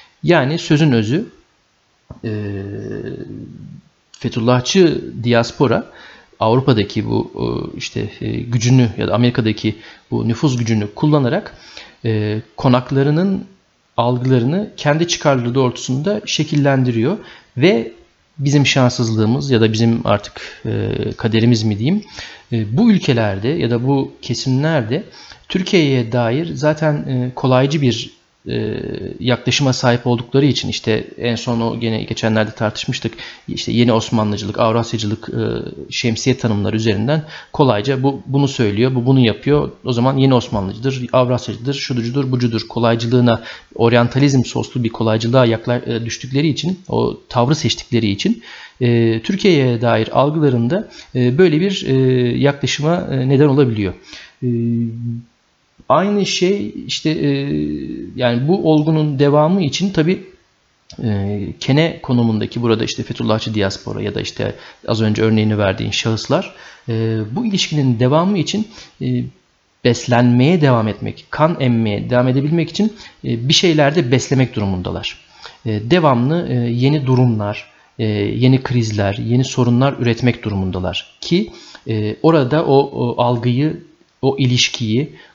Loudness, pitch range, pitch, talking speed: -17 LUFS, 115-140 Hz, 125 Hz, 110 wpm